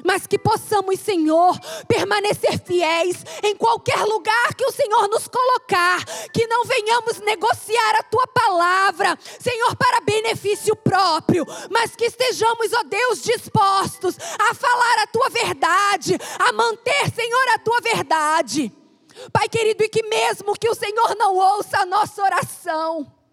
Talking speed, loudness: 140 wpm, -19 LUFS